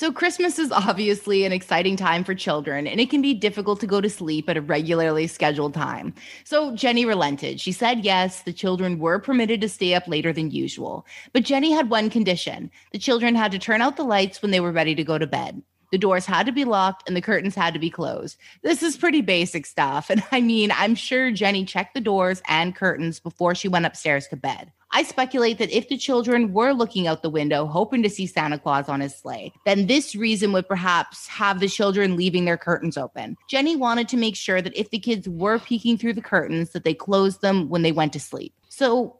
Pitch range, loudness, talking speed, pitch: 170-230 Hz, -22 LUFS, 230 wpm, 195 Hz